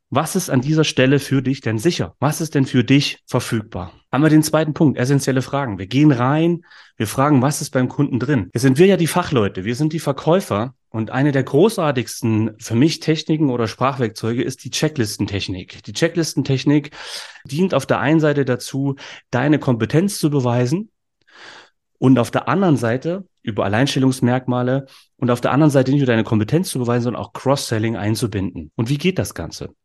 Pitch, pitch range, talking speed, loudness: 135 Hz, 120-150 Hz, 185 wpm, -18 LUFS